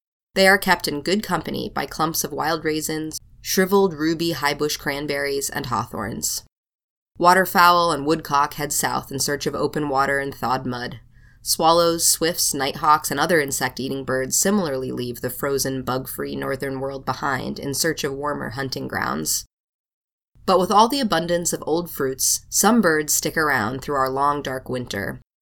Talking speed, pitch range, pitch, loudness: 165 wpm, 135-165 Hz, 145 Hz, -21 LUFS